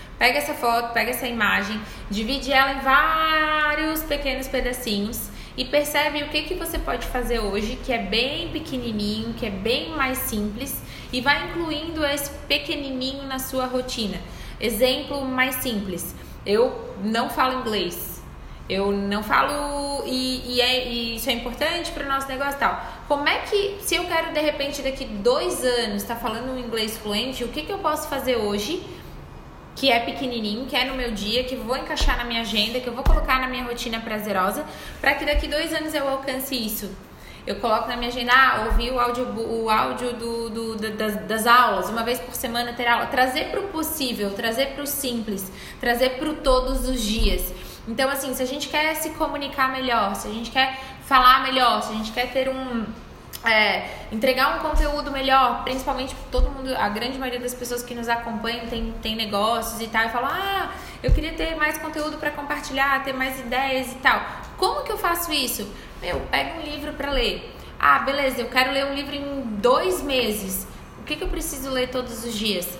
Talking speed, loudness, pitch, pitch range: 195 wpm, -23 LUFS, 255 Hz, 230-280 Hz